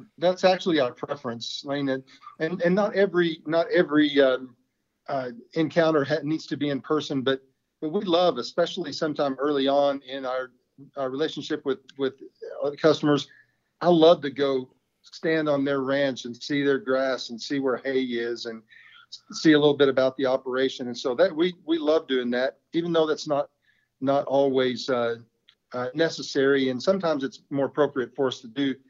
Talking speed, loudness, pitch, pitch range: 185 wpm, -25 LUFS, 140 Hz, 130-160 Hz